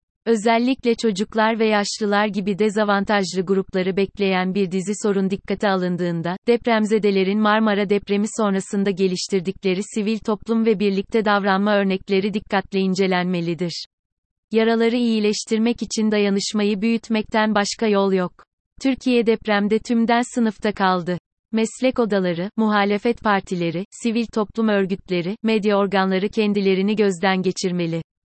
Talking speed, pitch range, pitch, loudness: 110 wpm, 190-220 Hz, 205 Hz, -20 LUFS